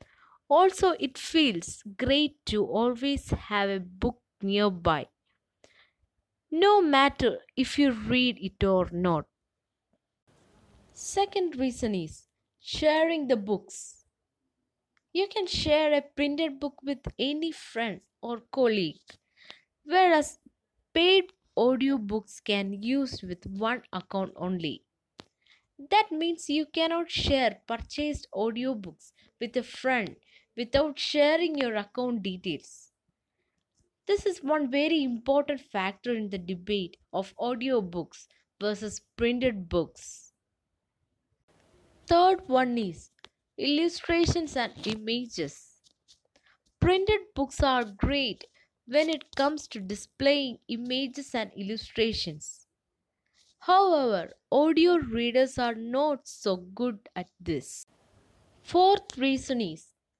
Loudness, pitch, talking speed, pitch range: -28 LUFS, 255 Hz, 105 wpm, 205-300 Hz